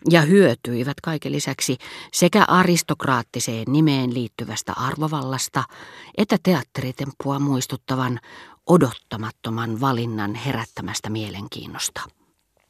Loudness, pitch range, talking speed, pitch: -22 LUFS, 115-155 Hz, 75 wpm, 130 Hz